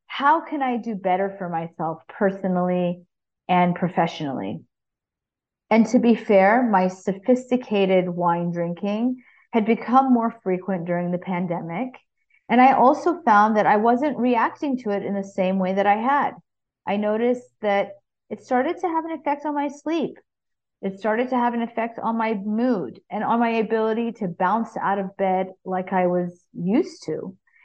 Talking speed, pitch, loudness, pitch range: 165 wpm, 215 Hz, -22 LUFS, 185-250 Hz